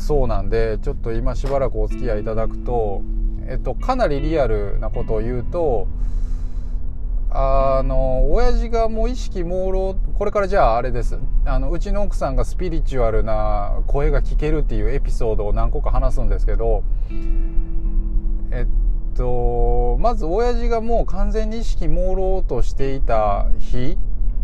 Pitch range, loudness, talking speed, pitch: 110-150 Hz, -23 LUFS, 310 characters per minute, 120 Hz